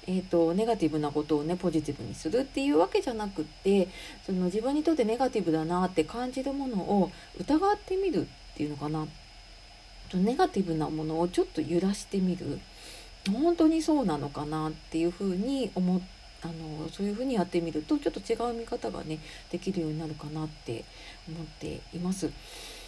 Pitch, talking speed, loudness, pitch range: 175 Hz, 390 characters per minute, -30 LUFS, 155-225 Hz